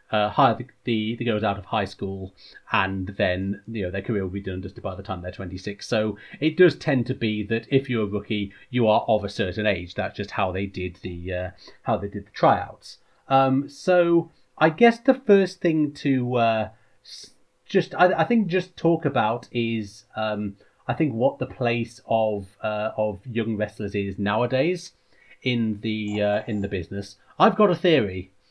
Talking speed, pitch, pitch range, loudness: 200 wpm, 110 Hz, 100-135 Hz, -24 LUFS